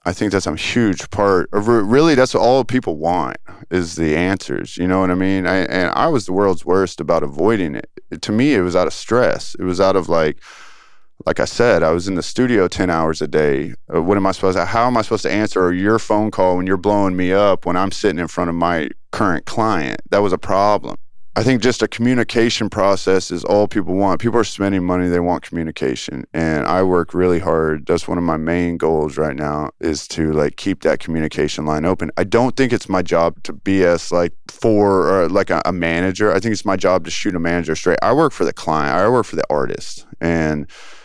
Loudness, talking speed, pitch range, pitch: -17 LUFS, 235 wpm, 85-100 Hz, 90 Hz